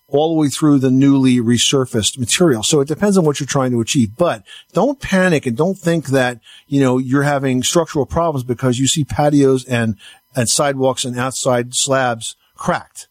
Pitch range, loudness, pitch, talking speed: 125-150 Hz, -16 LUFS, 135 Hz, 190 wpm